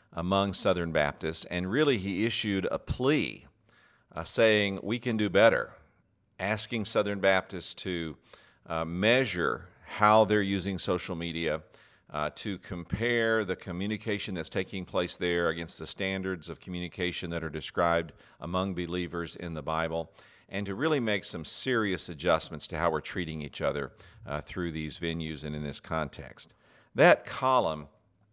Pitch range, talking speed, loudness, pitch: 80-100 Hz, 150 wpm, -29 LUFS, 90 Hz